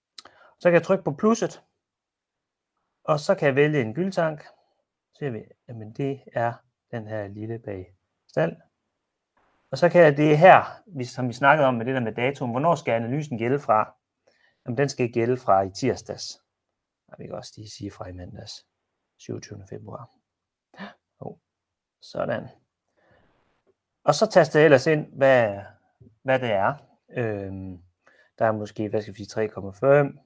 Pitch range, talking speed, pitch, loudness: 110-145 Hz, 160 wpm, 125 Hz, -23 LUFS